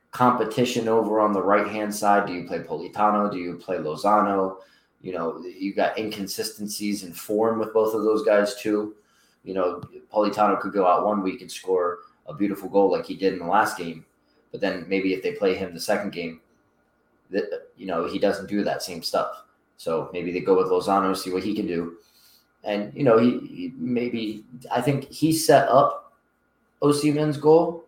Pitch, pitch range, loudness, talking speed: 105 Hz, 95-125 Hz, -24 LUFS, 200 wpm